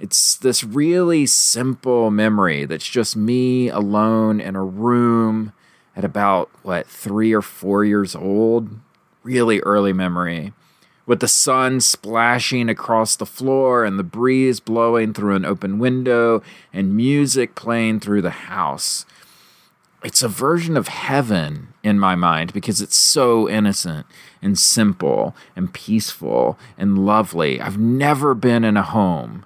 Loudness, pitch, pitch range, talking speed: -18 LUFS, 110 Hz, 100-125 Hz, 140 wpm